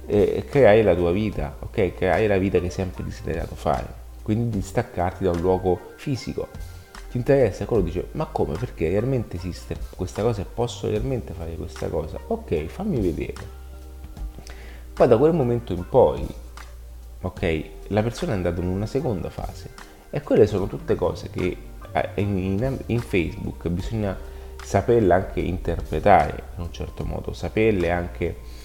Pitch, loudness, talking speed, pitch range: 90 Hz, -24 LUFS, 155 wpm, 80-105 Hz